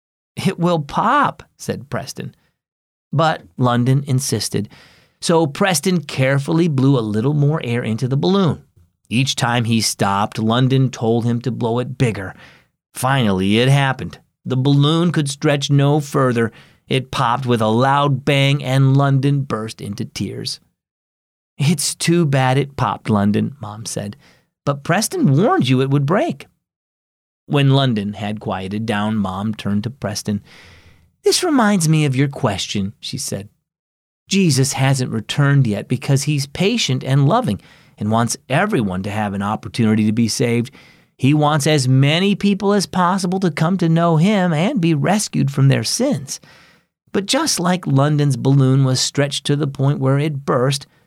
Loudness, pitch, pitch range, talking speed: -17 LUFS, 135 Hz, 115-155 Hz, 155 wpm